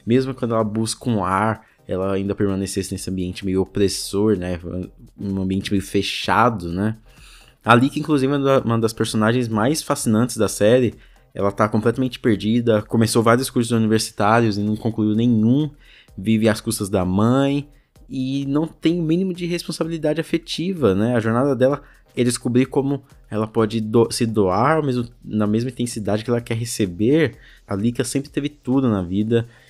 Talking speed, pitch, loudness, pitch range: 160 wpm, 115 Hz, -20 LUFS, 105-130 Hz